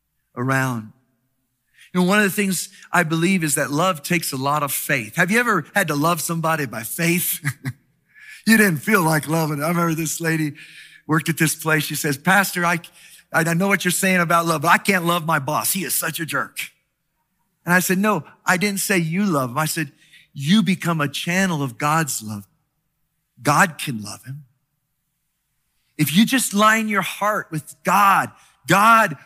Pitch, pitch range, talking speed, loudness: 160 Hz, 145-185 Hz, 190 wpm, -19 LUFS